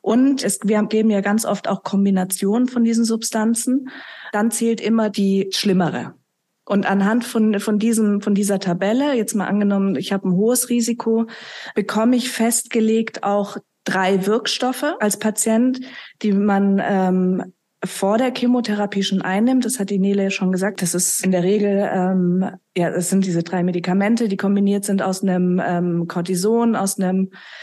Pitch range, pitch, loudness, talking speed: 190-225 Hz, 205 Hz, -19 LUFS, 165 wpm